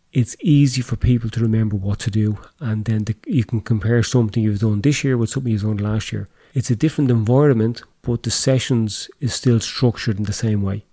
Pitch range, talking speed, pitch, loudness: 110-125 Hz, 220 wpm, 115 Hz, -19 LUFS